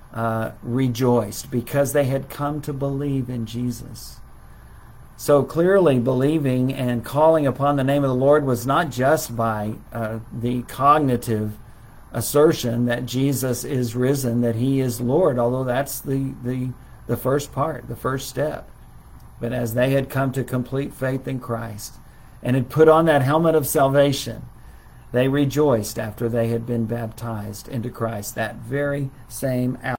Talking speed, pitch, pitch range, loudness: 155 wpm, 125 Hz, 120-140 Hz, -21 LUFS